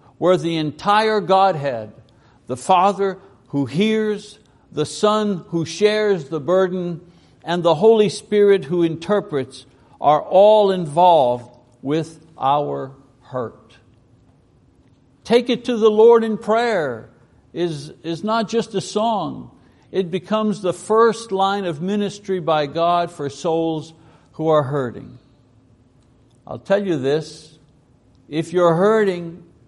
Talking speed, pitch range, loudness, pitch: 120 wpm, 140-205 Hz, -19 LUFS, 170 Hz